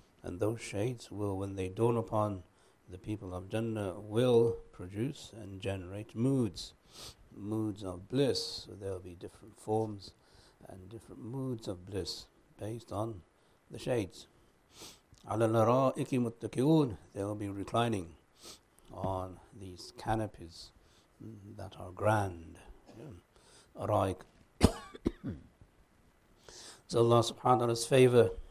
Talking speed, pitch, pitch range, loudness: 105 wpm, 105 Hz, 95-115 Hz, -33 LUFS